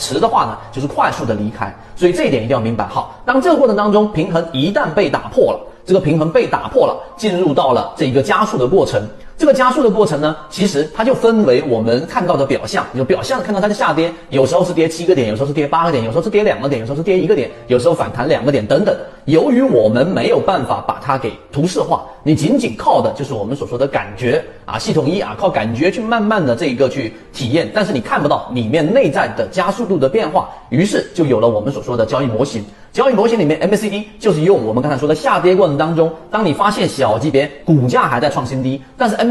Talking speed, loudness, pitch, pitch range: 375 characters per minute, -15 LUFS, 170 Hz, 140-210 Hz